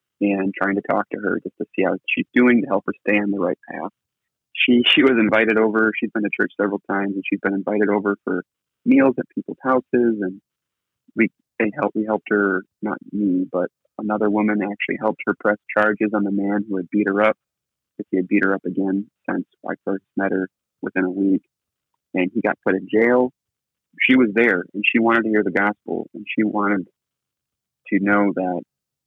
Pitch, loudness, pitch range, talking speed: 105 Hz, -20 LUFS, 95-110 Hz, 215 wpm